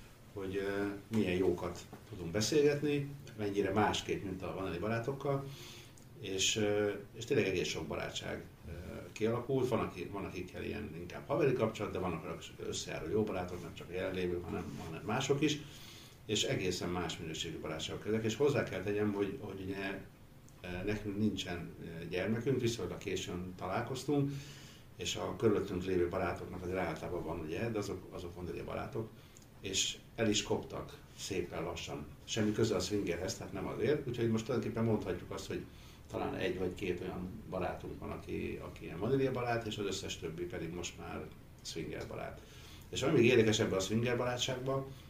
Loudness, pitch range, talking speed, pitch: -37 LUFS, 90-115 Hz, 160 wpm, 105 Hz